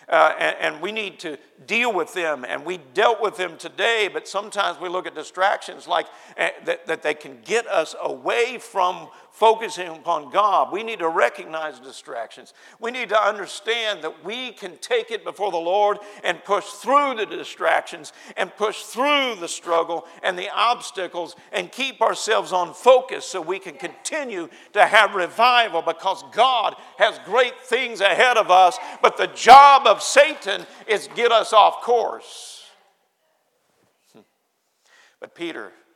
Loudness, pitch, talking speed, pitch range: -20 LUFS, 210 Hz, 160 wpm, 180-250 Hz